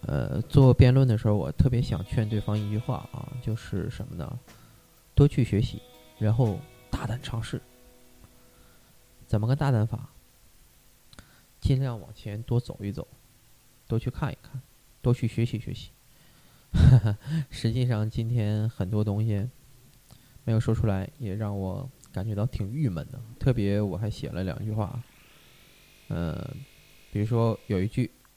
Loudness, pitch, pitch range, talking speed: -27 LUFS, 115 Hz, 105-125 Hz, 210 characters per minute